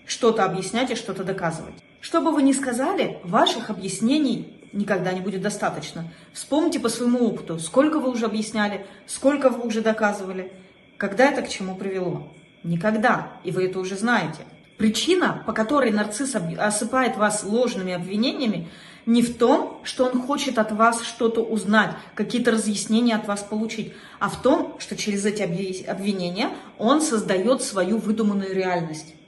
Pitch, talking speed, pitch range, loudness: 215 Hz, 150 wpm, 190-245 Hz, -23 LUFS